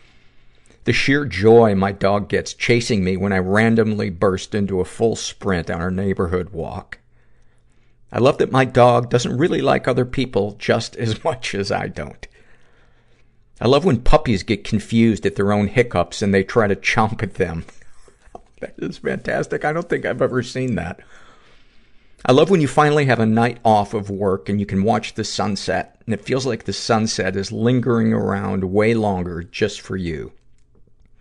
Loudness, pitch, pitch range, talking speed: -19 LUFS, 105 Hz, 95-115 Hz, 180 wpm